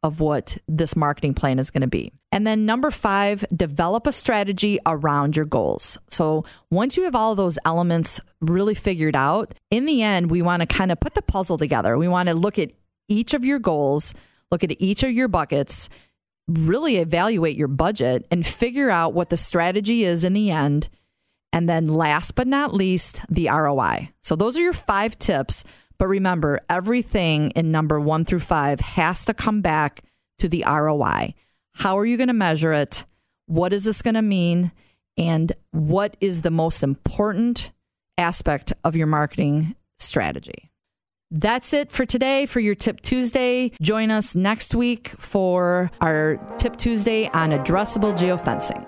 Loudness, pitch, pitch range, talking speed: -21 LUFS, 175 Hz, 155-215 Hz, 175 wpm